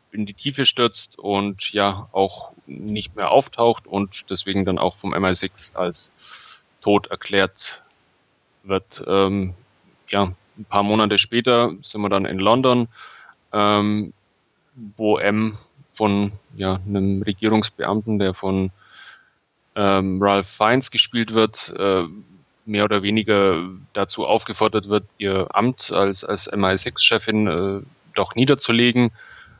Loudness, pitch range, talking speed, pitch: -20 LUFS, 95-110 Hz, 120 wpm, 105 Hz